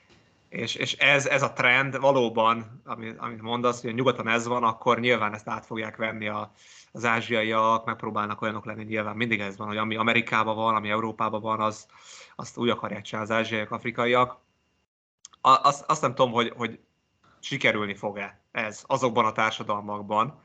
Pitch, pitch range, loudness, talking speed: 110 Hz, 110-120 Hz, -25 LUFS, 170 wpm